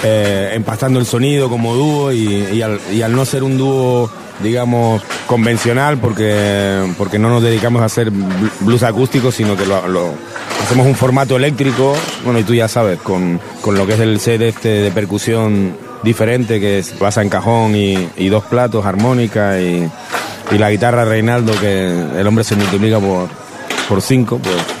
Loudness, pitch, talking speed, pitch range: -14 LUFS, 110 Hz, 180 wpm, 100-120 Hz